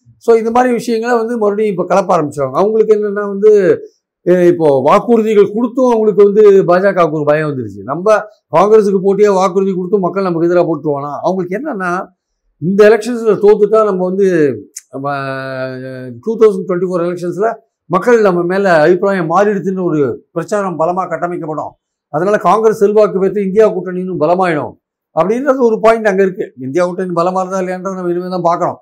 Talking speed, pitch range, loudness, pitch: 150 wpm, 175-215 Hz, -12 LUFS, 190 Hz